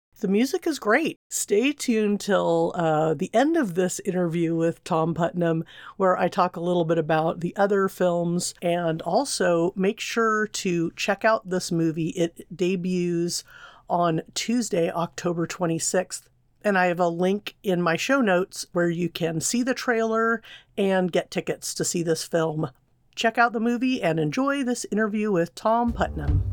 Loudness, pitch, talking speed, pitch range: -24 LUFS, 180 Hz, 165 wpm, 165-215 Hz